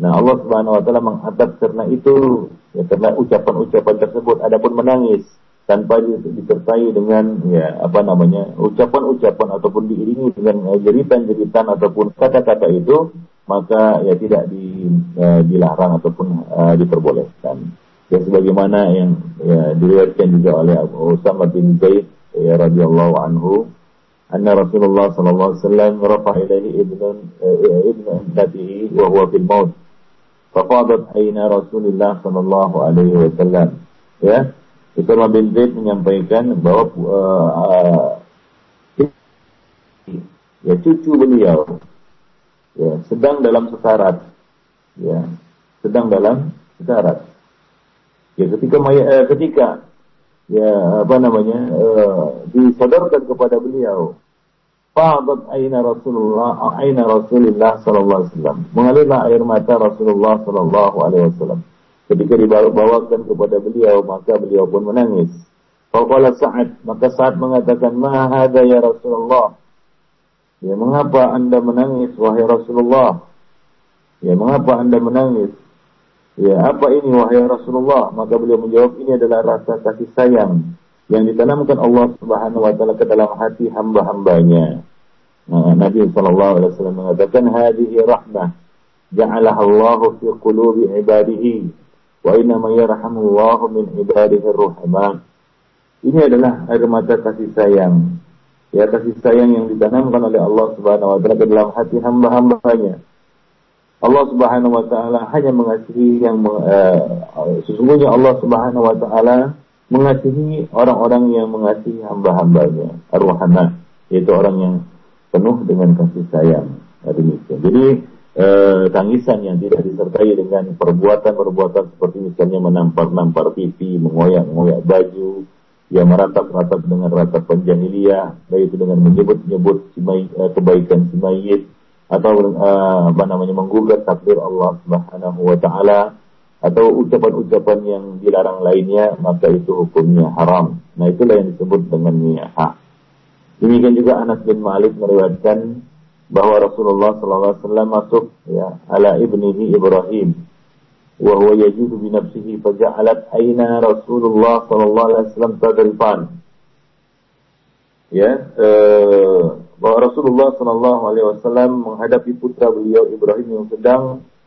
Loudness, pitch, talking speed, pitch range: -13 LUFS, 110 Hz, 110 wpm, 95-125 Hz